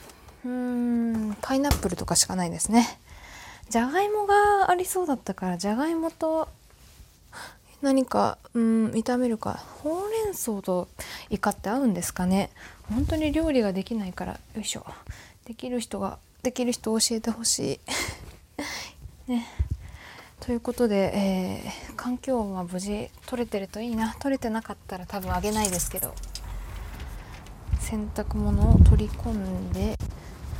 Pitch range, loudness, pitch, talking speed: 185-255 Hz, -27 LUFS, 225 Hz, 285 characters per minute